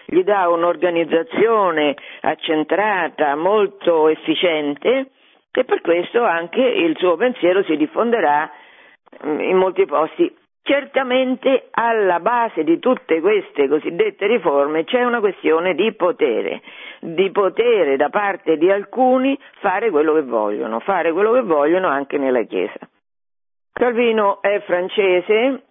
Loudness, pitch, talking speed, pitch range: -18 LUFS, 210 Hz, 120 wpm, 170-270 Hz